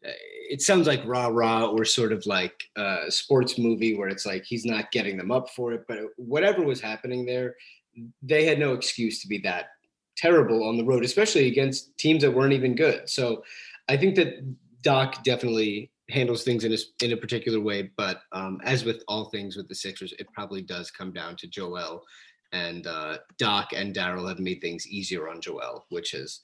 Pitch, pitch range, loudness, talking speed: 115 Hz, 105-130 Hz, -26 LUFS, 200 wpm